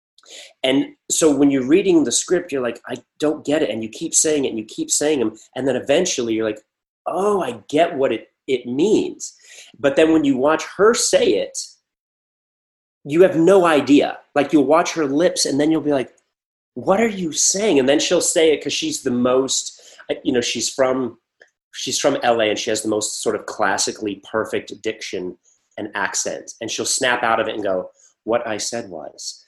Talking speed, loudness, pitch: 205 wpm, -19 LUFS, 150 Hz